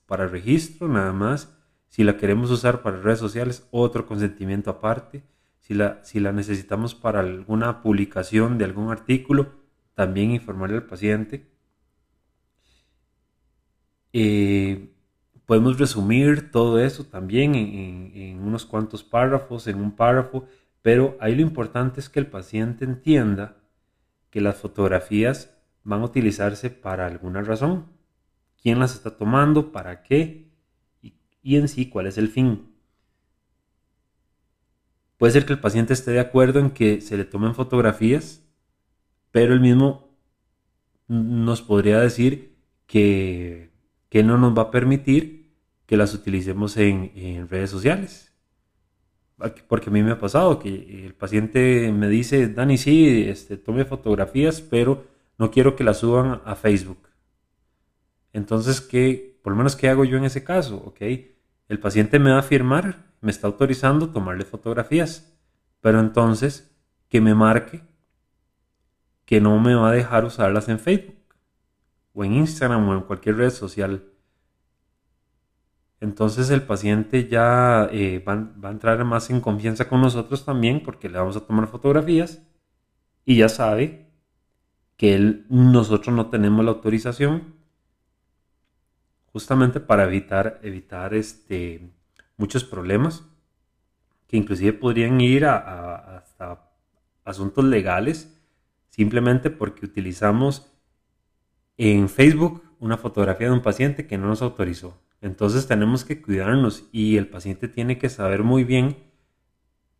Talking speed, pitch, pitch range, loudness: 135 wpm, 110 Hz, 100-130 Hz, -21 LUFS